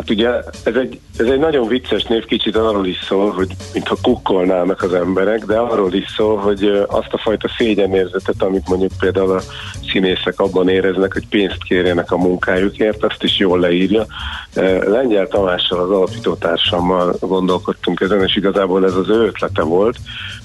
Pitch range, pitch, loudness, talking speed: 95-105 Hz, 95 Hz, -16 LUFS, 165 wpm